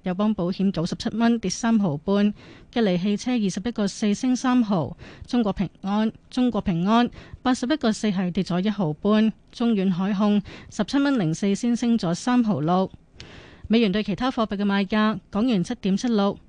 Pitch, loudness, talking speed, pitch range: 210 Hz, -23 LUFS, 270 characters per minute, 195-235 Hz